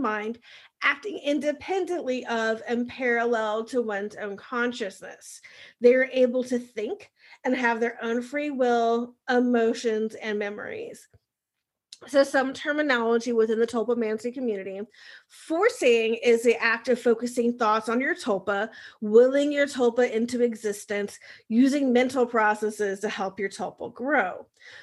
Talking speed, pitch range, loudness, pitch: 135 wpm, 220-255 Hz, -25 LUFS, 235 Hz